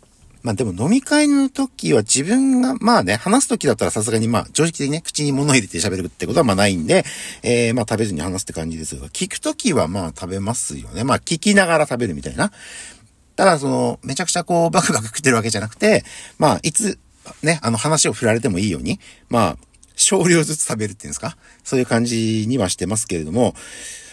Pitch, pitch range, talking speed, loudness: 125 Hz, 110-175 Hz, 435 characters per minute, -18 LUFS